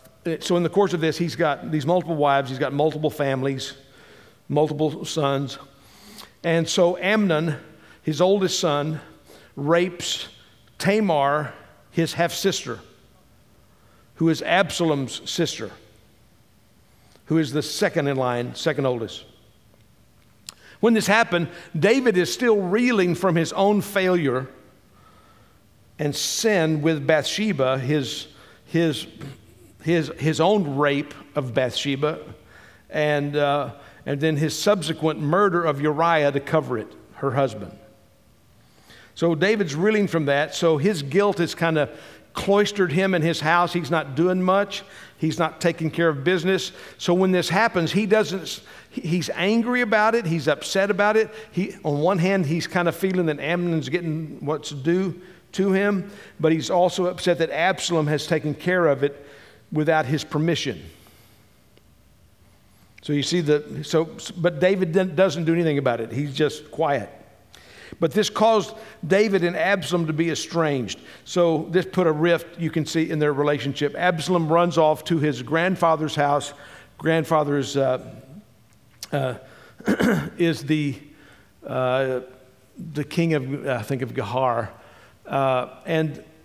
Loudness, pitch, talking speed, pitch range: -22 LUFS, 160 Hz, 140 wpm, 145-180 Hz